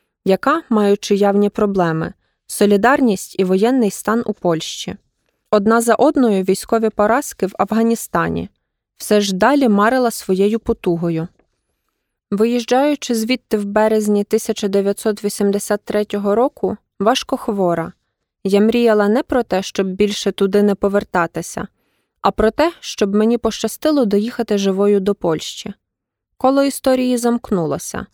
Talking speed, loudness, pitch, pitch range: 115 wpm, -17 LUFS, 210 Hz, 200-235 Hz